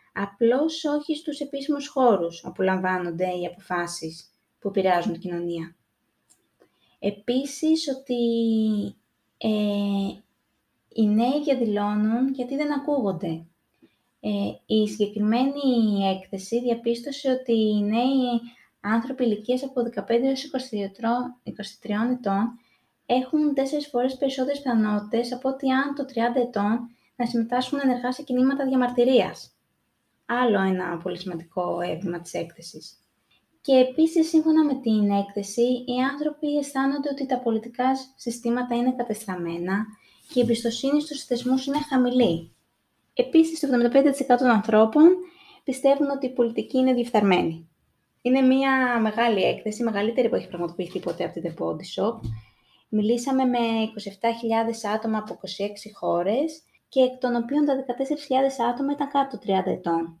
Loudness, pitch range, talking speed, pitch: -24 LUFS, 205-265 Hz, 125 wpm, 240 Hz